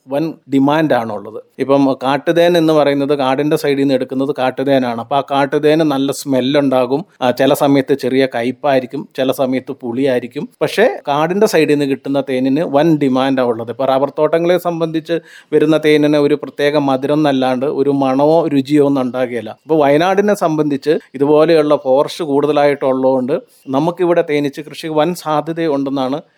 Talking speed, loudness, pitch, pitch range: 130 wpm, -14 LUFS, 140 Hz, 135-155 Hz